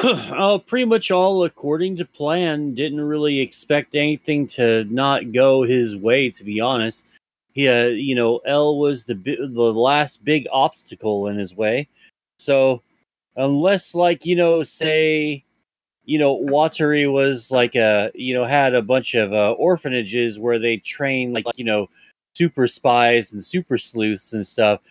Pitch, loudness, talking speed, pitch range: 135 Hz, -19 LUFS, 160 wpm, 120-150 Hz